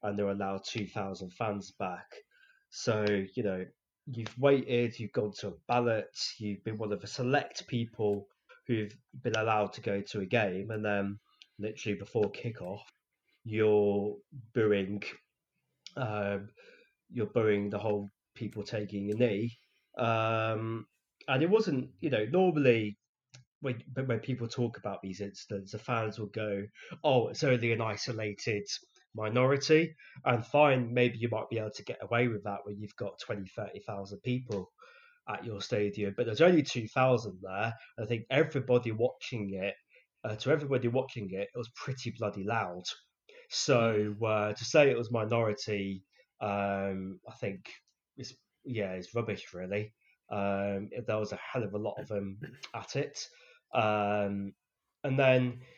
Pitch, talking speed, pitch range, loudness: 110 Hz, 160 wpm, 100-125 Hz, -32 LUFS